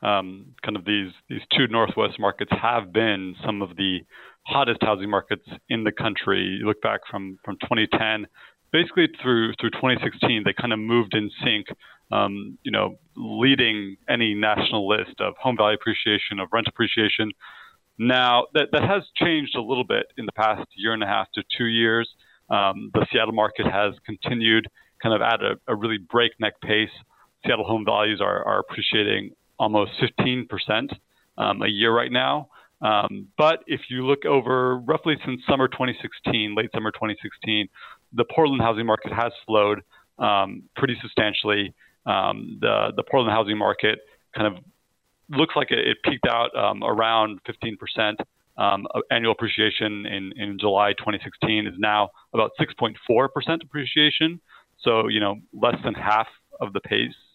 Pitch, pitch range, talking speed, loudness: 110 Hz, 105-125 Hz, 160 wpm, -23 LUFS